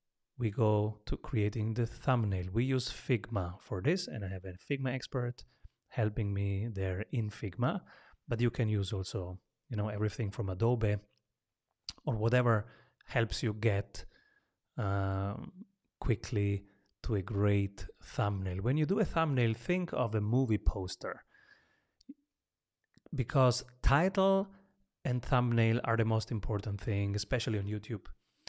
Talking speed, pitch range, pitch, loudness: 135 wpm, 100-125 Hz, 115 Hz, -34 LUFS